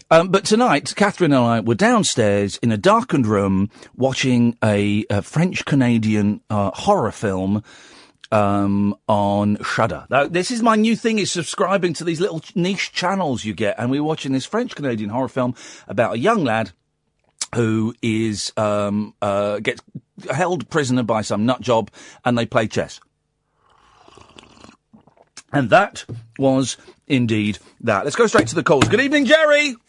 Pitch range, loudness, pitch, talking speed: 105-170 Hz, -19 LUFS, 120 Hz, 160 wpm